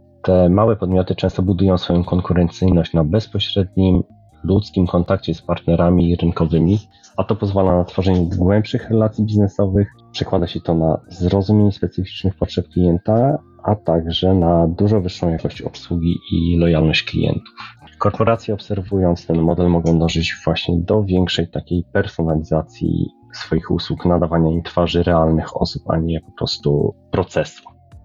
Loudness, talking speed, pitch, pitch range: -18 LUFS, 135 wpm, 90 Hz, 85-100 Hz